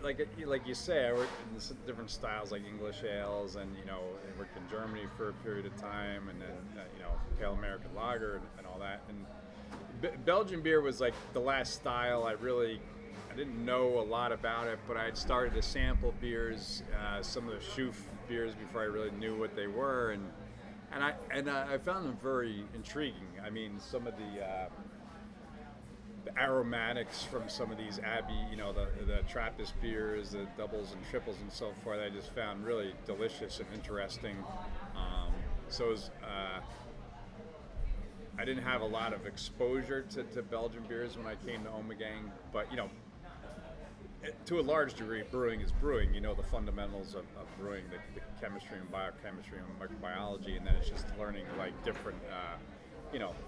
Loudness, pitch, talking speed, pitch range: -38 LUFS, 105 Hz, 190 wpm, 100-120 Hz